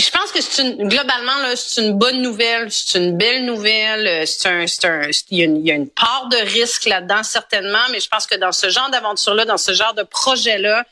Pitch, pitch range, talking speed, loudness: 220 Hz, 195-245 Hz, 245 wpm, -15 LUFS